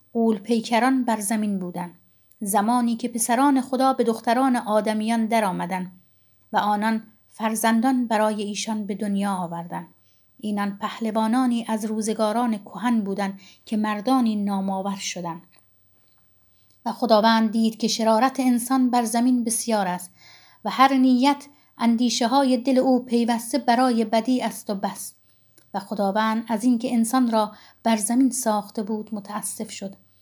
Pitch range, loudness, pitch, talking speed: 205-240 Hz, -23 LUFS, 225 Hz, 135 wpm